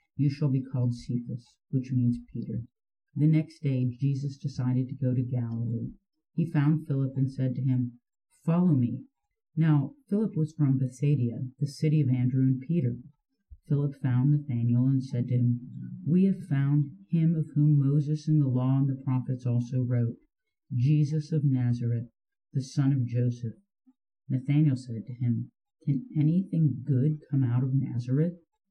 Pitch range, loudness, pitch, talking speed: 125-155 Hz, -28 LUFS, 135 Hz, 160 wpm